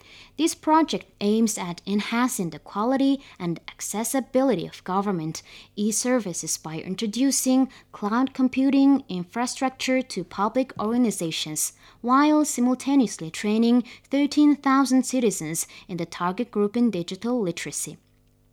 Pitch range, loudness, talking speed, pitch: 180-260 Hz, -24 LUFS, 105 wpm, 230 Hz